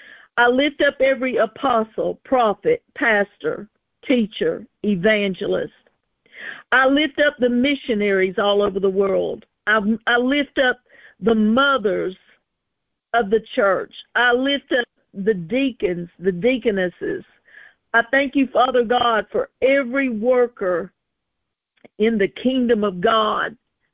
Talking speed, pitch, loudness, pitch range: 120 wpm, 240 Hz, -19 LUFS, 210-270 Hz